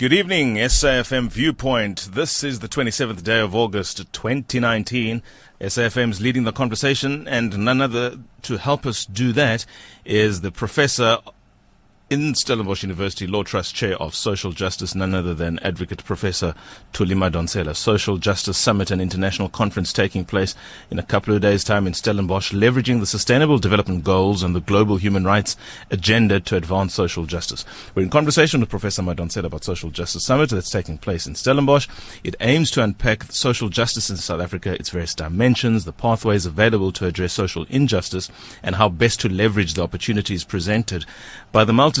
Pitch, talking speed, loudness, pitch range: 105 Hz, 170 wpm, -20 LUFS, 95-120 Hz